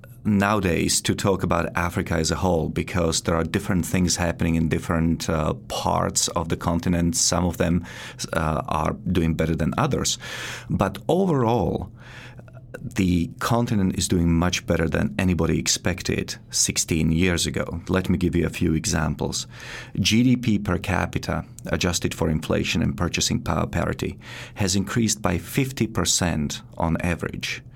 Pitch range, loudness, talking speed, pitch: 85-100 Hz, -23 LUFS, 145 wpm, 90 Hz